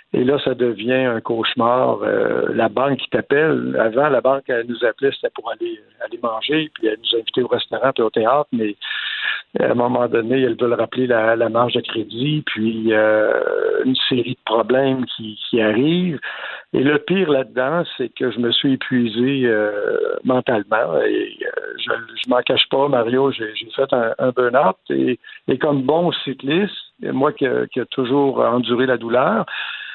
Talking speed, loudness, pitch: 185 wpm, -19 LUFS, 130 Hz